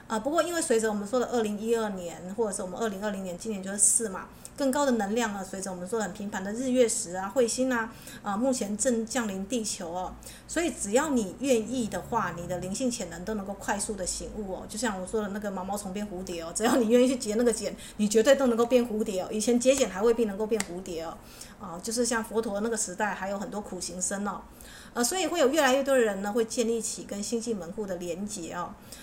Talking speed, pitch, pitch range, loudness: 370 characters per minute, 220 Hz, 195-240 Hz, -28 LUFS